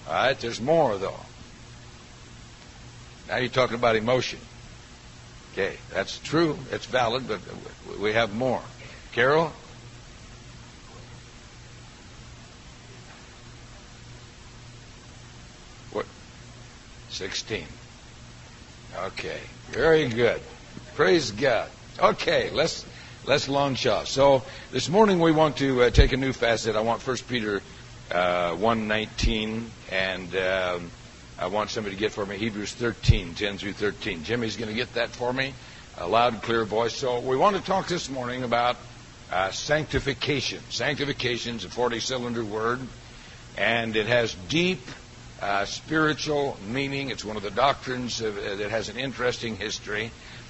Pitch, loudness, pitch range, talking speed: 120 Hz, -26 LUFS, 110-130 Hz, 130 wpm